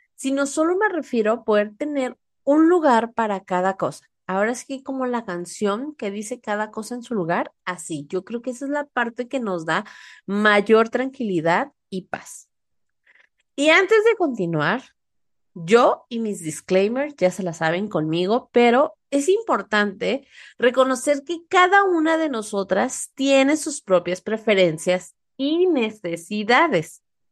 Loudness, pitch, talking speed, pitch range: -21 LUFS, 235 Hz, 150 wpm, 195-280 Hz